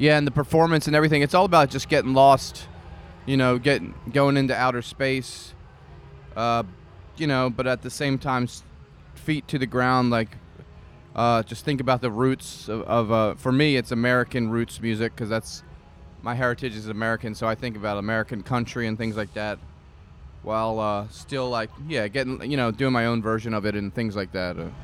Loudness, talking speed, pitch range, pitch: -24 LUFS, 200 wpm, 105-130 Hz, 115 Hz